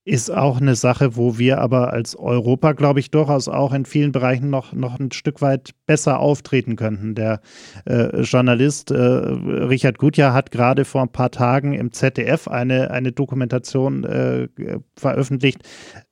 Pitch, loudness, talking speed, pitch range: 130 Hz, -19 LUFS, 160 wpm, 125-140 Hz